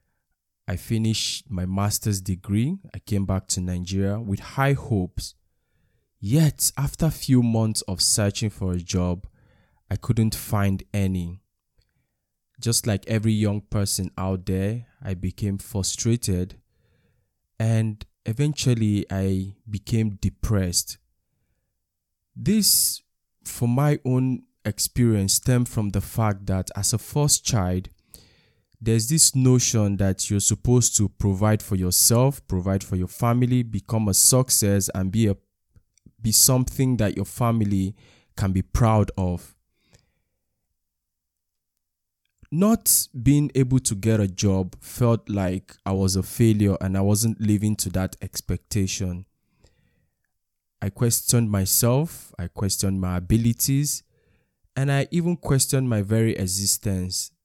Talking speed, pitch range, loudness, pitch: 125 wpm, 95-120 Hz, -22 LUFS, 105 Hz